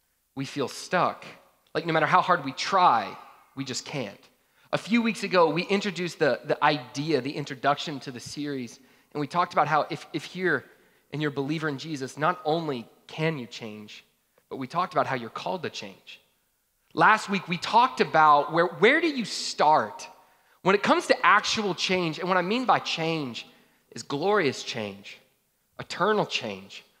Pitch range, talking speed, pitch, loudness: 140-185 Hz, 180 wpm, 155 Hz, -25 LUFS